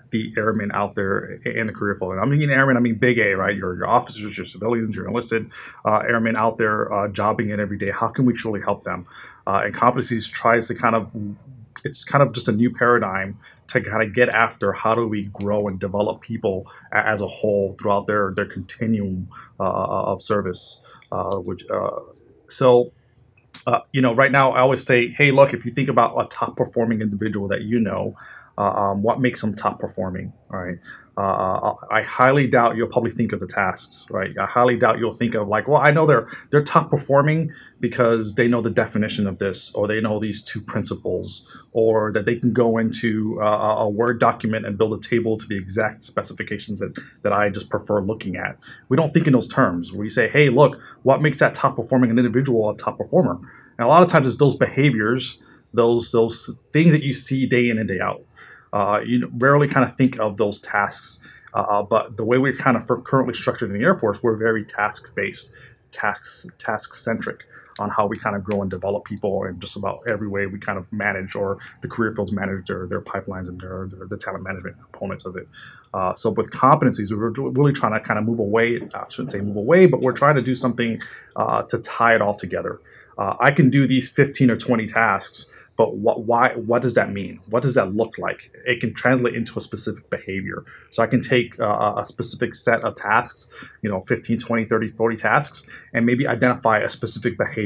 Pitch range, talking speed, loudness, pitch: 105-125 Hz, 220 wpm, -20 LUFS, 115 Hz